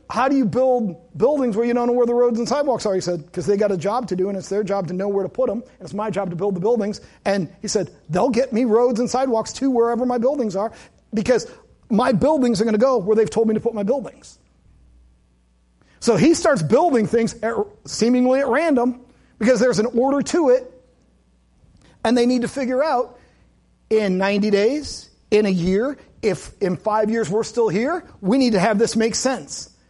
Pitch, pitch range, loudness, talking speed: 225 Hz, 200-250 Hz, -20 LUFS, 225 wpm